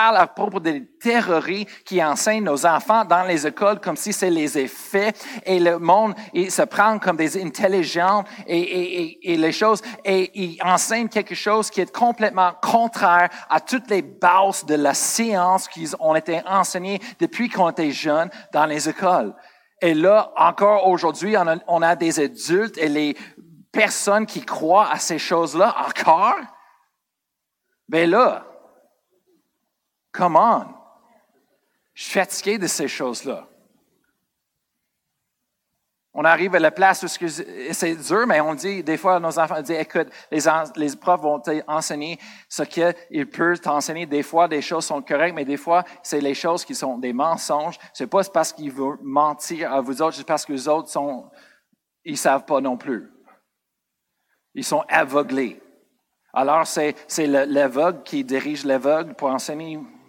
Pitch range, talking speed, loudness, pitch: 155-200 Hz, 160 wpm, -20 LUFS, 170 Hz